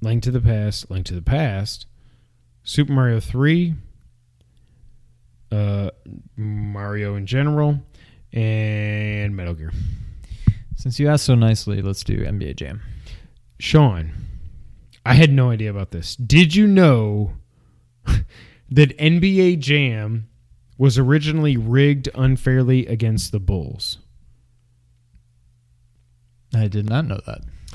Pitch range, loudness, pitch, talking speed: 100-130 Hz, -19 LUFS, 110 Hz, 110 wpm